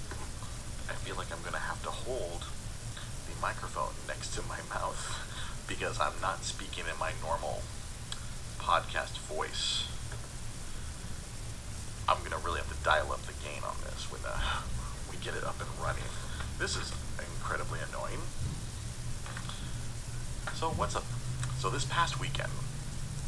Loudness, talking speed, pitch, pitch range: -36 LUFS, 135 wpm, 120 Hz, 80-130 Hz